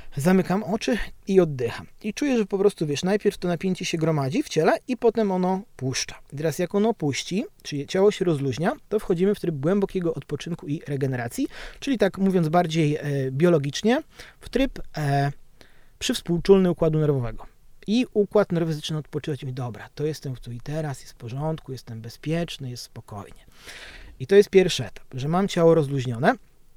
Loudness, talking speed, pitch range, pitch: -24 LUFS, 175 wpm, 140-195 Hz, 165 Hz